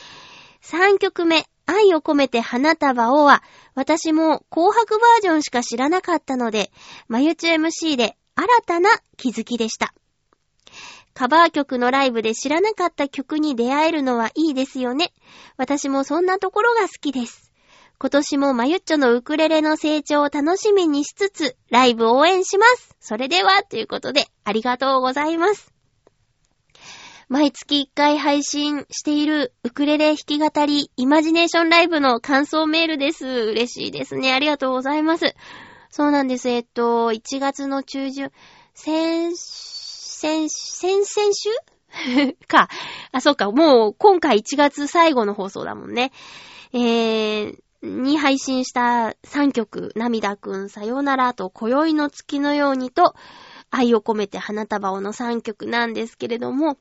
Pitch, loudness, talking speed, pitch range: 285 Hz, -19 LUFS, 290 characters per minute, 245-320 Hz